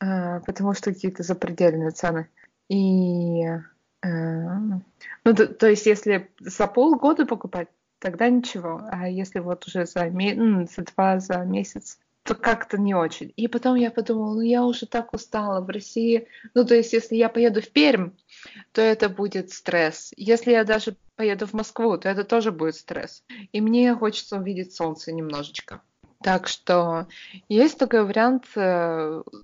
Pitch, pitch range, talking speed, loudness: 200 Hz, 180-230 Hz, 155 wpm, -23 LUFS